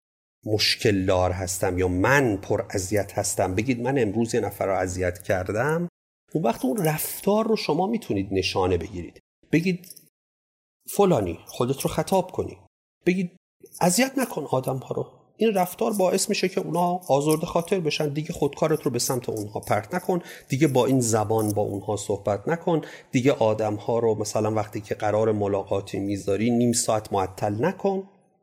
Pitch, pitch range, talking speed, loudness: 130 Hz, 105-175 Hz, 160 wpm, -24 LUFS